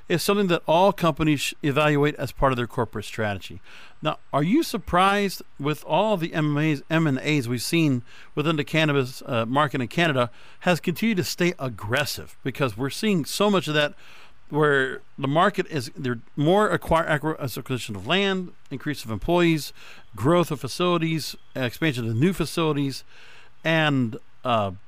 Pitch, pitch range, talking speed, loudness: 150 Hz, 130-170 Hz, 155 wpm, -24 LUFS